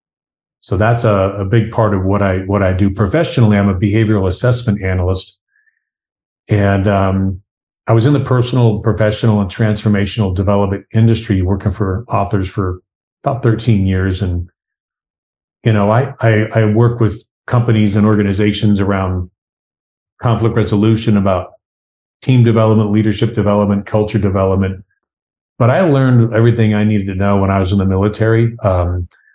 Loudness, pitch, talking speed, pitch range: -14 LUFS, 105 Hz, 150 wpm, 100-110 Hz